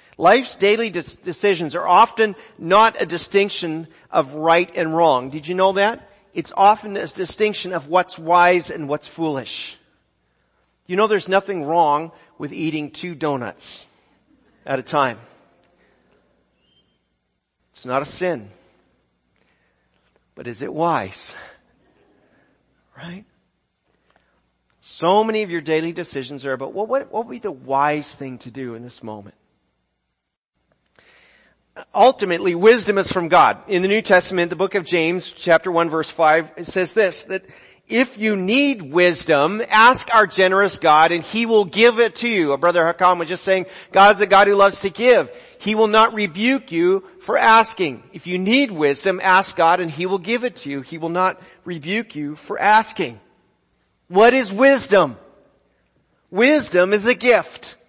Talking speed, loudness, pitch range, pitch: 160 wpm, -17 LUFS, 160-210 Hz, 180 Hz